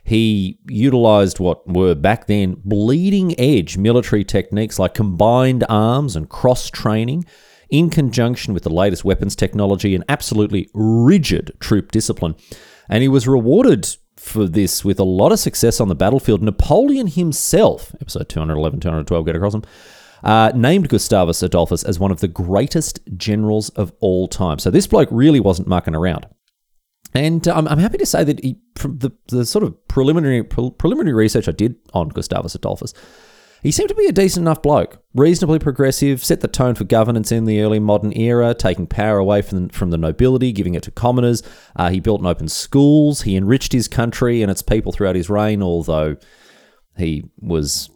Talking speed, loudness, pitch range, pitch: 180 wpm, -16 LUFS, 95-130 Hz, 110 Hz